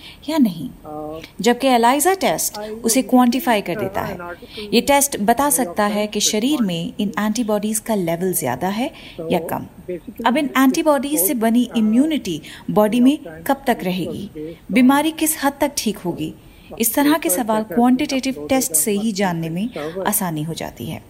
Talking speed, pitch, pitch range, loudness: 160 wpm, 225 Hz, 190-265 Hz, -18 LUFS